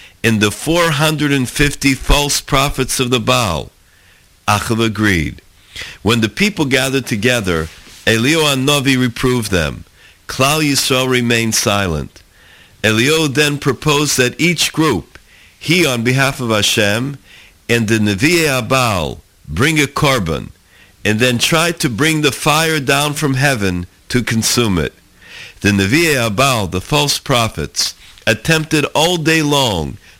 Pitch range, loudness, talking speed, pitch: 105-145 Hz, -14 LUFS, 130 wpm, 125 Hz